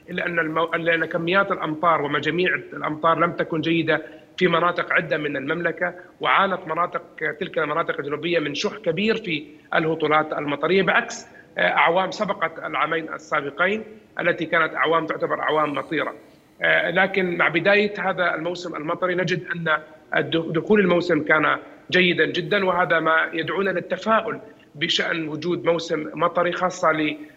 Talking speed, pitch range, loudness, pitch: 130 wpm, 155-180 Hz, -22 LUFS, 170 Hz